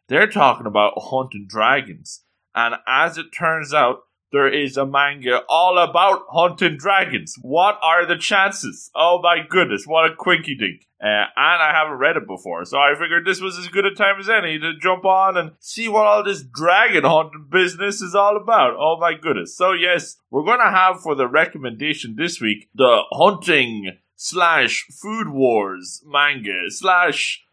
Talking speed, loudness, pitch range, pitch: 180 wpm, -17 LUFS, 130-185 Hz, 165 Hz